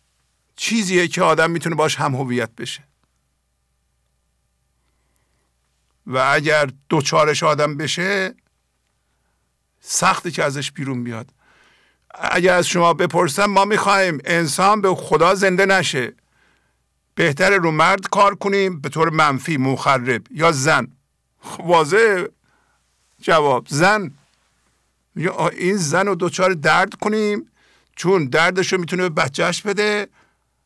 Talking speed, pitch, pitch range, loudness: 110 wpm, 155 Hz, 110-185 Hz, -17 LUFS